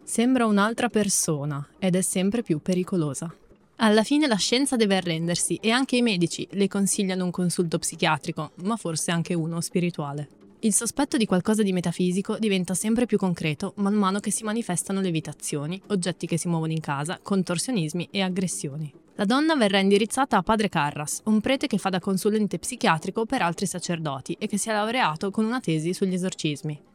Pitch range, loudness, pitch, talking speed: 170-215 Hz, -25 LUFS, 190 Hz, 180 wpm